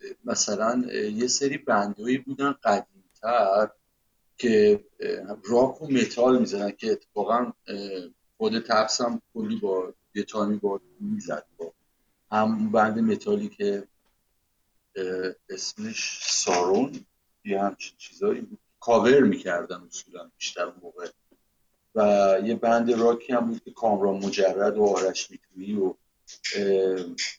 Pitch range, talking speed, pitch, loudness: 100-140 Hz, 105 wpm, 110 Hz, -25 LUFS